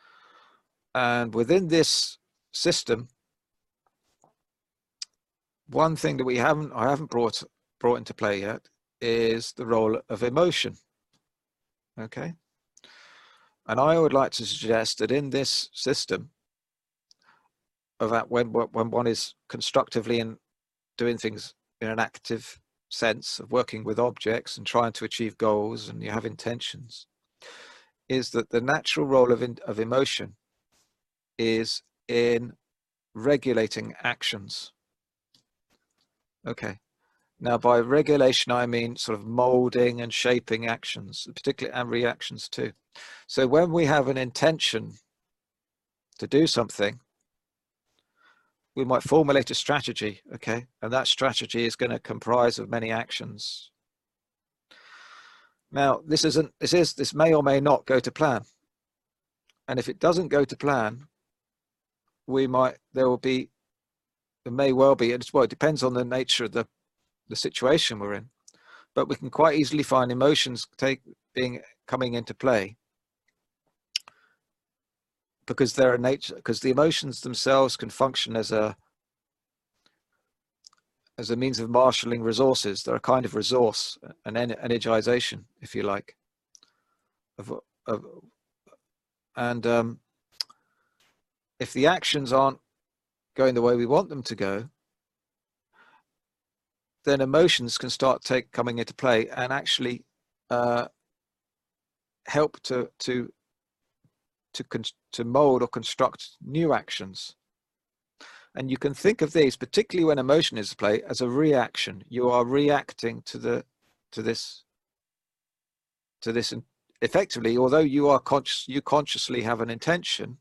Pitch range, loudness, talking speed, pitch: 115-140 Hz, -25 LUFS, 135 wpm, 125 Hz